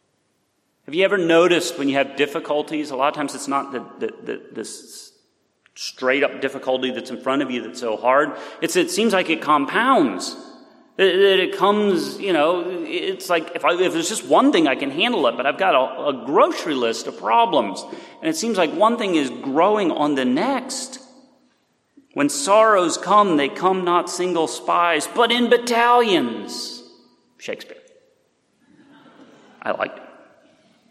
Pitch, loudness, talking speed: 210 Hz, -19 LUFS, 170 wpm